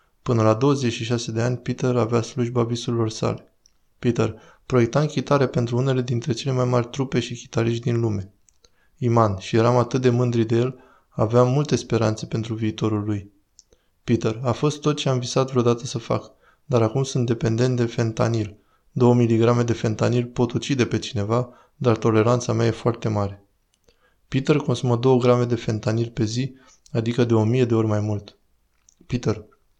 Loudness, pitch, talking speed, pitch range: -22 LUFS, 120 Hz, 170 wpm, 110-125 Hz